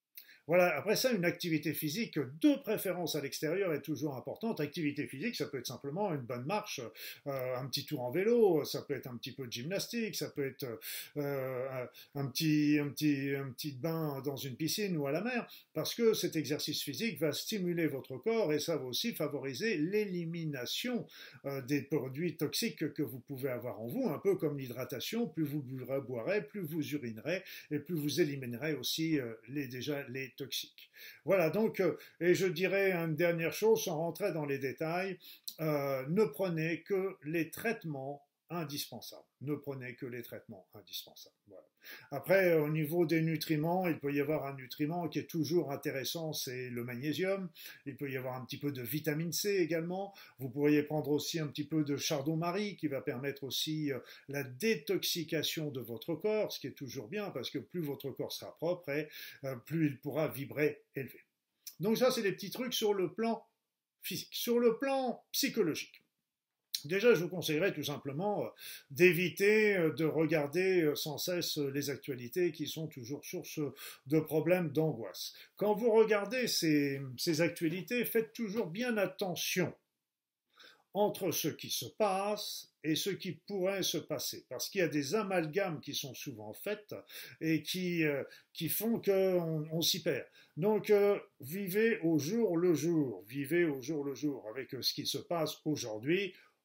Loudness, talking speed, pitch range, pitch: -35 LUFS, 180 wpm, 140-185 Hz, 155 Hz